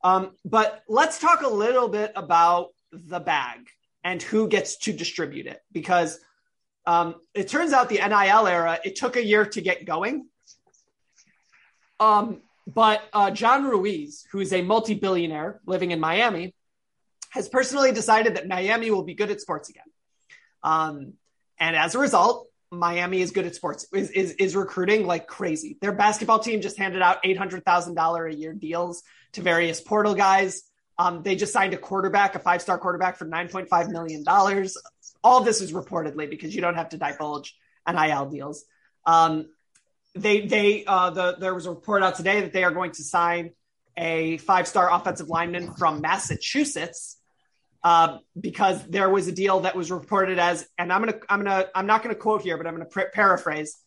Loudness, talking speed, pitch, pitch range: -23 LUFS, 175 wpm, 185 Hz, 170-210 Hz